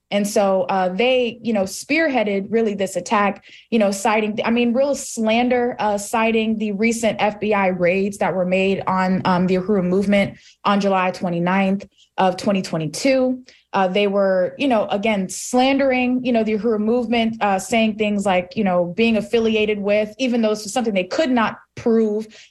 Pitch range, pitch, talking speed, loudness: 195-230 Hz, 210 Hz, 175 wpm, -19 LUFS